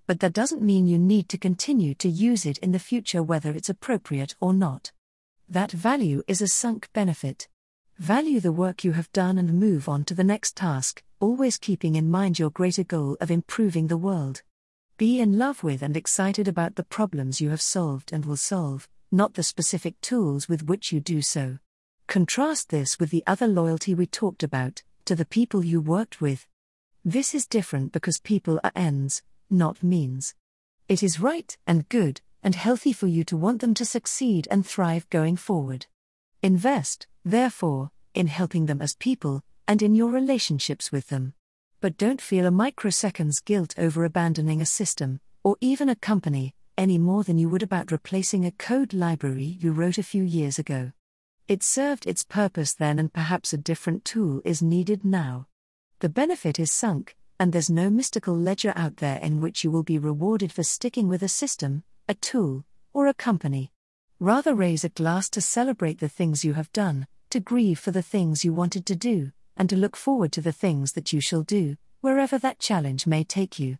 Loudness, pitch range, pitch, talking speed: -25 LUFS, 155-205 Hz, 175 Hz, 190 wpm